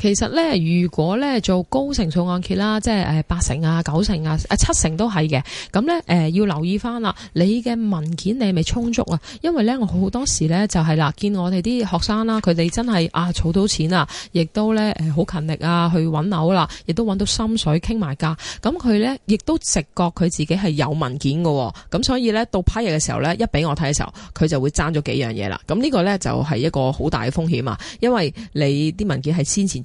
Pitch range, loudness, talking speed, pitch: 155-215 Hz, -20 LUFS, 320 characters per minute, 175 Hz